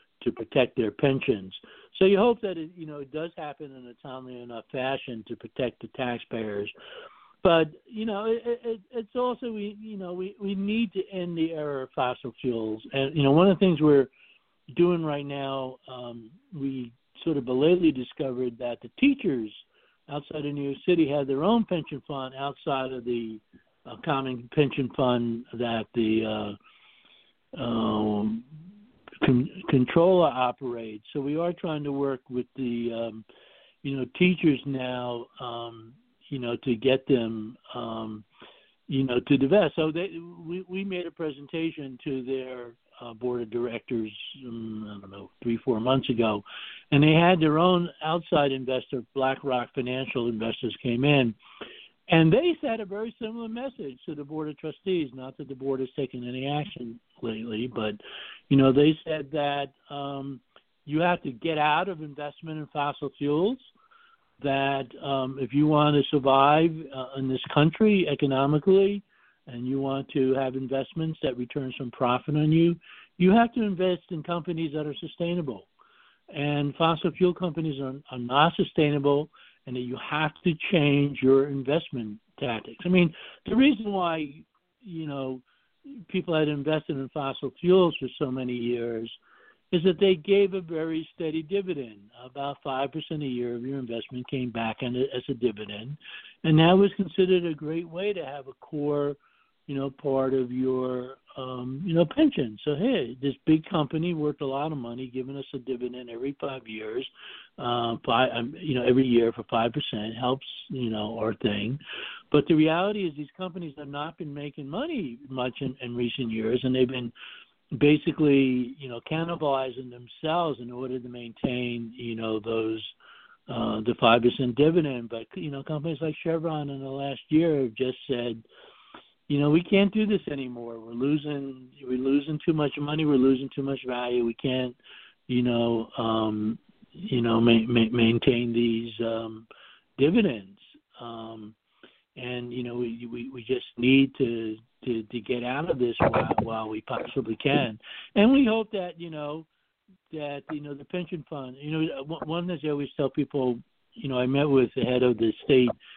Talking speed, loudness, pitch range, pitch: 175 wpm, -27 LUFS, 125-160 Hz, 140 Hz